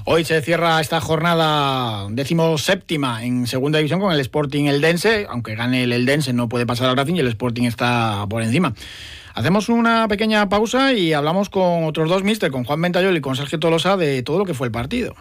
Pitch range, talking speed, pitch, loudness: 125-175 Hz, 215 wpm, 150 Hz, -19 LUFS